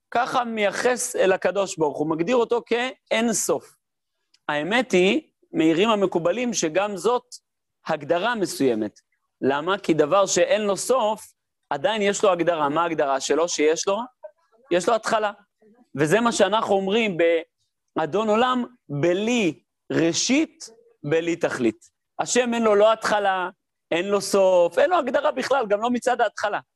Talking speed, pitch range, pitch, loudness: 140 wpm, 175-245 Hz, 205 Hz, -22 LUFS